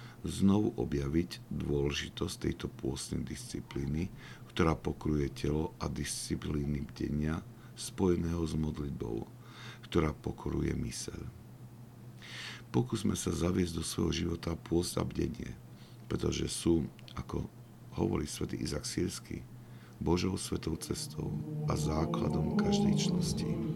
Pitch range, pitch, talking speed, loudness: 75-115 Hz, 85 Hz, 100 wpm, -35 LUFS